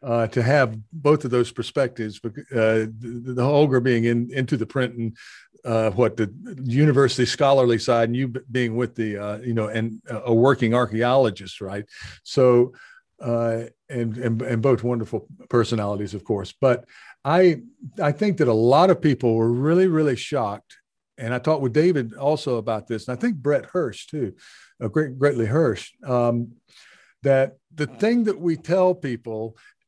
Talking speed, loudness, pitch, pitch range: 170 wpm, -22 LUFS, 125 Hz, 115-145 Hz